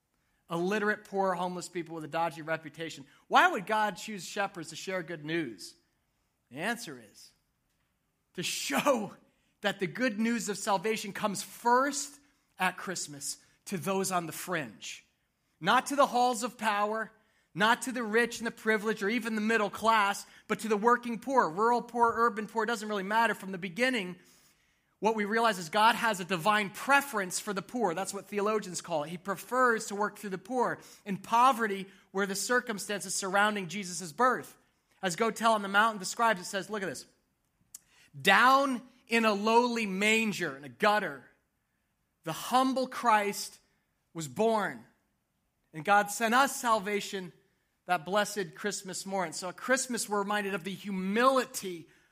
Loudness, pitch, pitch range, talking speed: -30 LUFS, 210 Hz, 190-230 Hz, 165 wpm